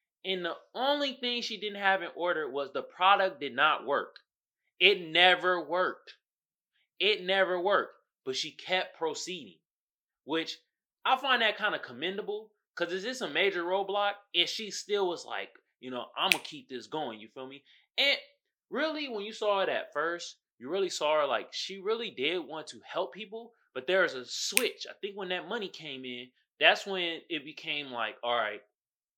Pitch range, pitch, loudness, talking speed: 160-230 Hz, 190 Hz, -30 LUFS, 190 wpm